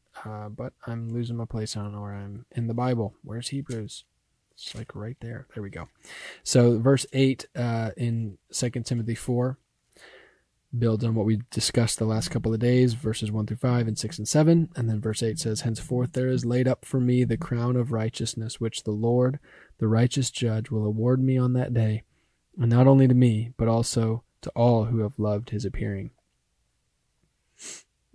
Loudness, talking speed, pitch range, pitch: -25 LUFS, 195 wpm, 110-125 Hz, 115 Hz